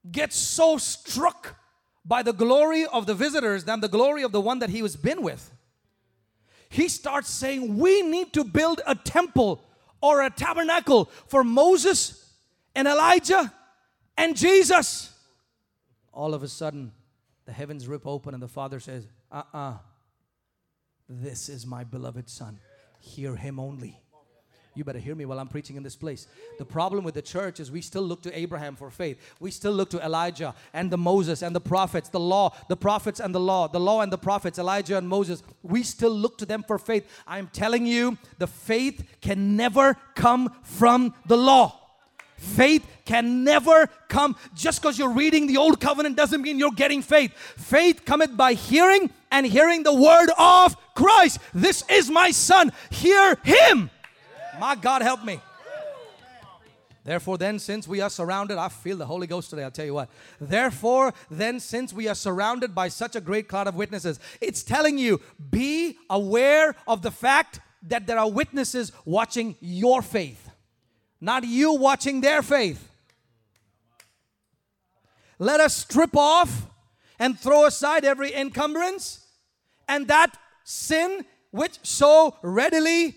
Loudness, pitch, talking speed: -21 LUFS, 220 Hz, 165 wpm